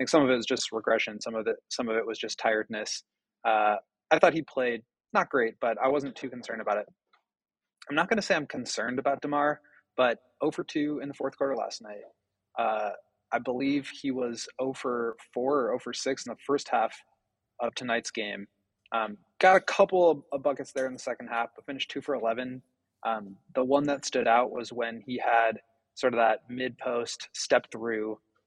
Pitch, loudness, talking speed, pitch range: 125 Hz, -29 LUFS, 200 wpm, 115-140 Hz